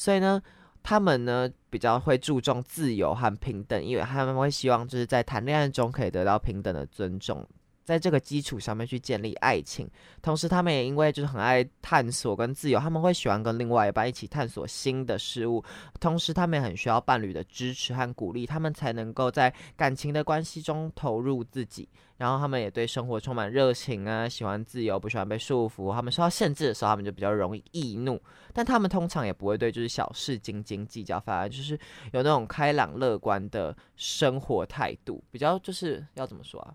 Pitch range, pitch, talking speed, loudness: 115-145 Hz, 125 Hz, 325 characters per minute, -28 LUFS